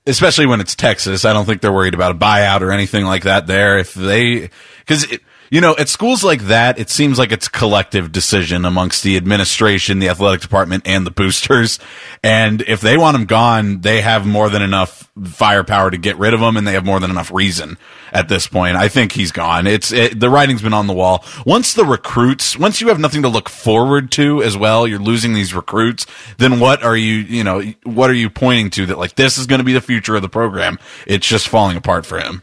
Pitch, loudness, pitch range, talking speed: 105 Hz, -13 LUFS, 95-120 Hz, 235 wpm